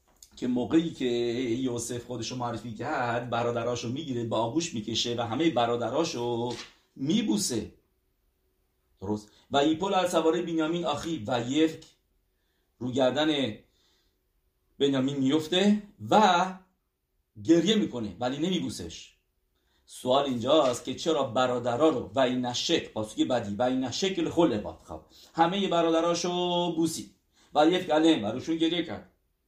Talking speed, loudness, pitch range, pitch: 120 wpm, -27 LUFS, 115-165 Hz, 125 Hz